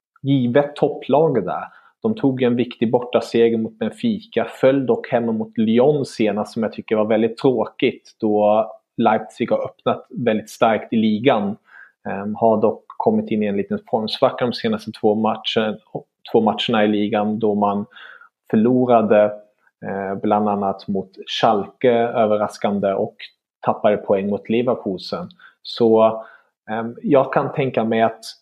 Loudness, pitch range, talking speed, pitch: -19 LUFS, 105-120 Hz, 145 wpm, 110 Hz